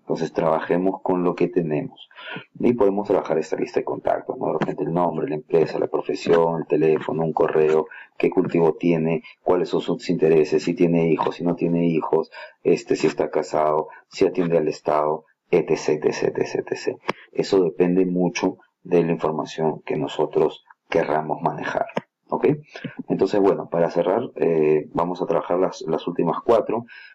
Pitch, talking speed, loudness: 85 Hz, 165 wpm, -22 LUFS